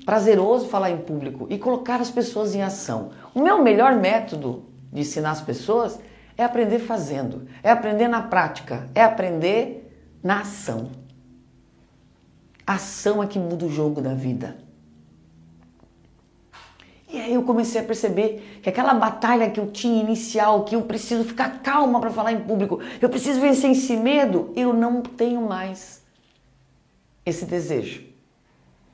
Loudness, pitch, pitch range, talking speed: -22 LUFS, 215 Hz, 155-235 Hz, 145 wpm